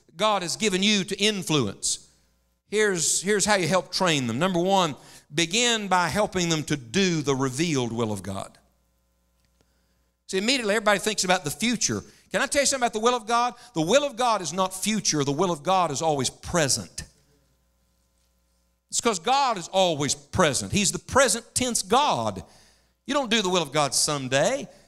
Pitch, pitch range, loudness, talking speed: 180 Hz, 130-210 Hz, -24 LUFS, 185 wpm